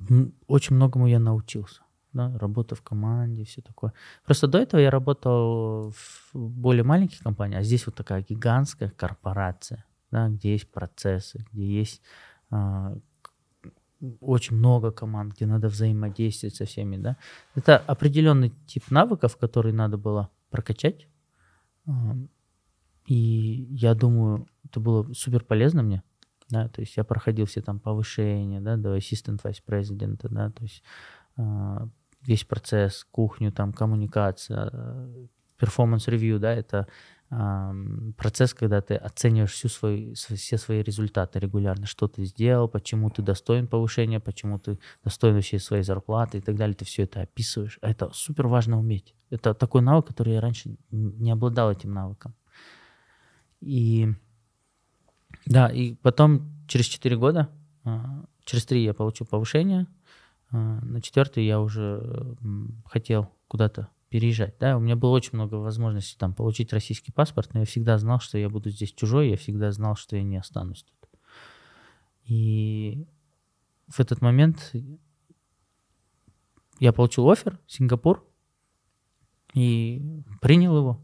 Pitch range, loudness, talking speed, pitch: 105-125 Hz, -25 LUFS, 135 wpm, 115 Hz